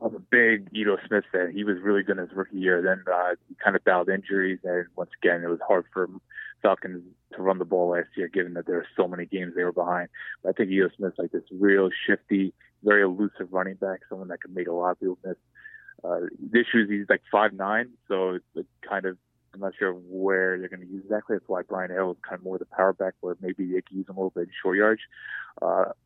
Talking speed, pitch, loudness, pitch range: 265 wpm, 95 Hz, -26 LUFS, 90-95 Hz